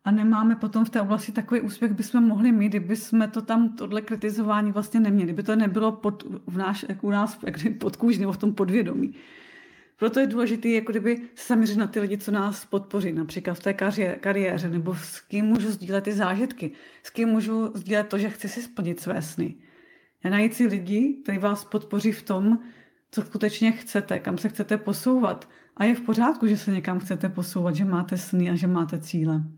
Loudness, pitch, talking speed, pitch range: -25 LUFS, 210 Hz, 205 wpm, 195-225 Hz